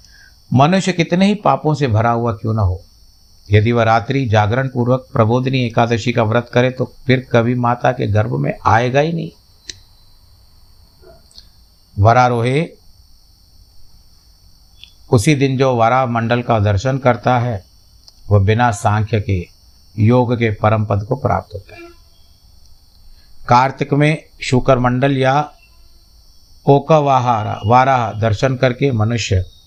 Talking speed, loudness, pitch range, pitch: 125 wpm, -15 LUFS, 90-125 Hz, 115 Hz